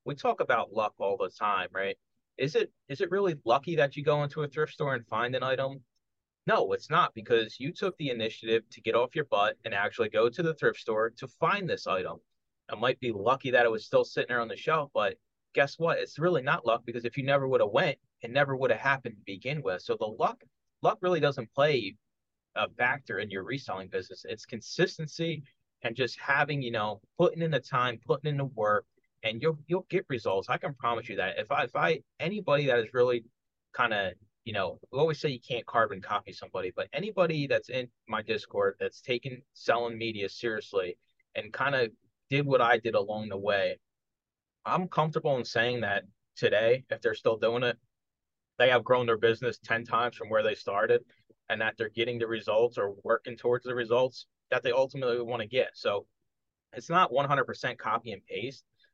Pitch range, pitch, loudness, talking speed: 120-190 Hz, 140 Hz, -30 LUFS, 215 wpm